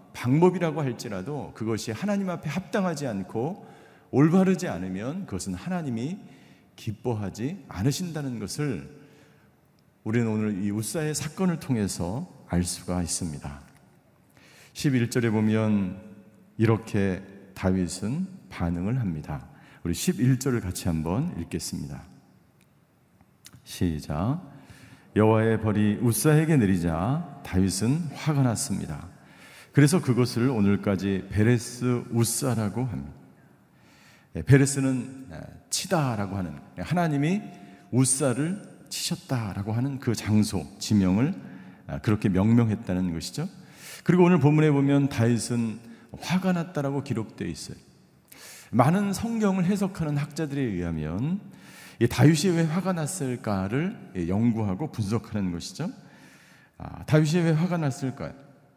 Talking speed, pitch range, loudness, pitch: 265 characters per minute, 100-150 Hz, -26 LUFS, 120 Hz